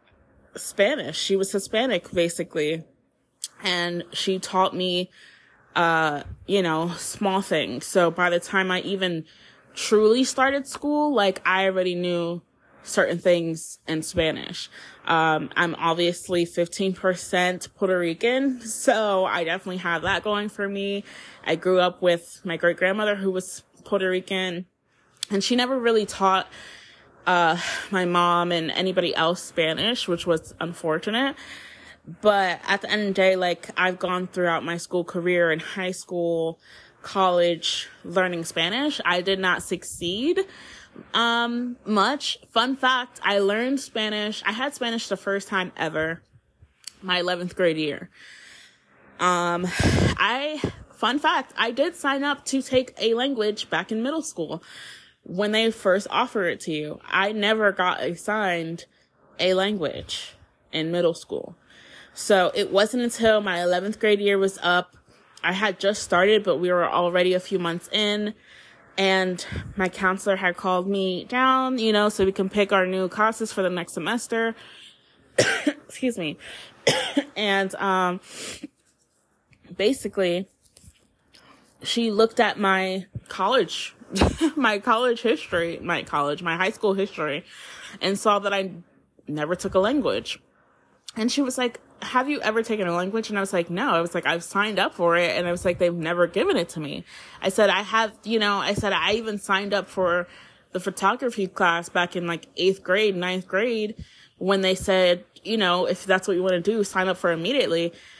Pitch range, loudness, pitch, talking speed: 175-215 Hz, -23 LUFS, 190 Hz, 160 wpm